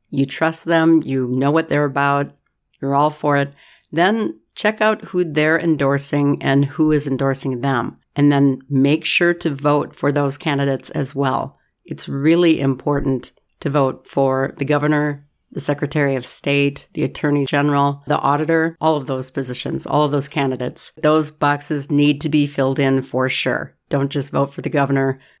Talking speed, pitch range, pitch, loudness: 175 wpm, 135-150 Hz, 145 Hz, -18 LUFS